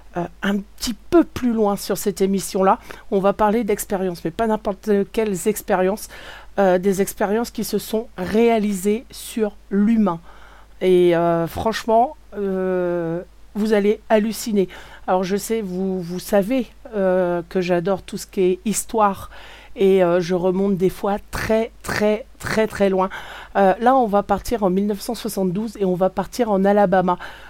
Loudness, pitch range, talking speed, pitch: -20 LUFS, 185-220 Hz, 155 wpm, 200 Hz